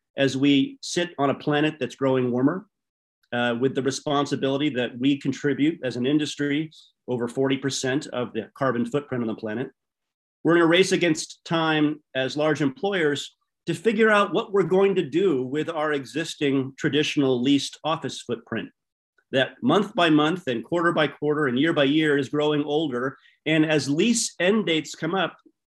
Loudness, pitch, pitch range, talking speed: -24 LUFS, 150 Hz, 135-165 Hz, 175 wpm